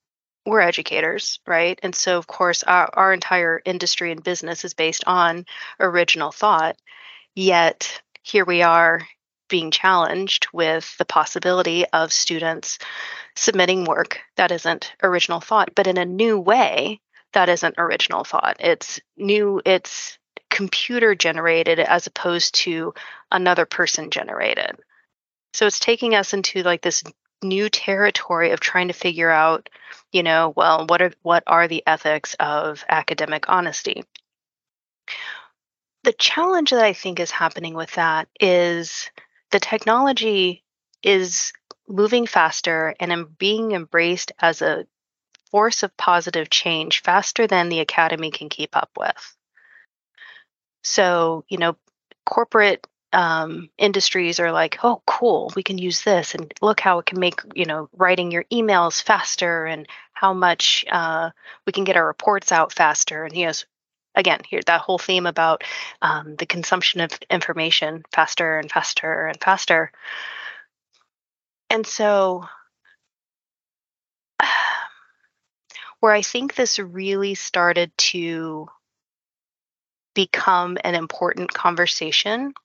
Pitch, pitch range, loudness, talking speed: 180 Hz, 165-195 Hz, -19 LUFS, 135 wpm